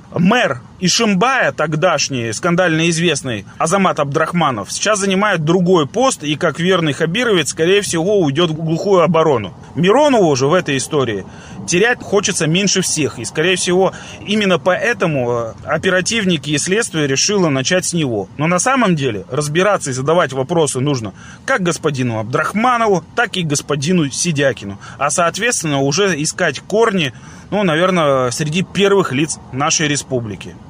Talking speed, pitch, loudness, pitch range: 135 wpm, 165 Hz, -15 LUFS, 145-185 Hz